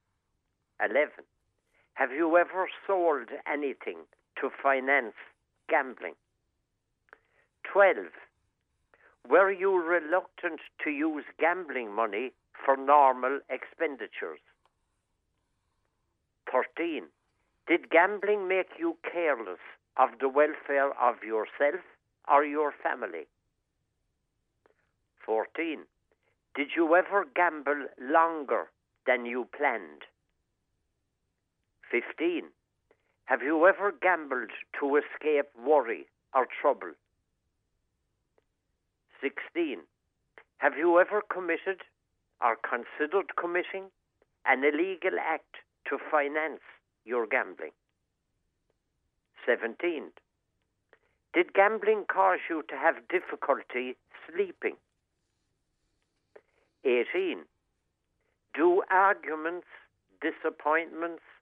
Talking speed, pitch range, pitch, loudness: 80 wpm, 130-195 Hz, 160 Hz, -29 LUFS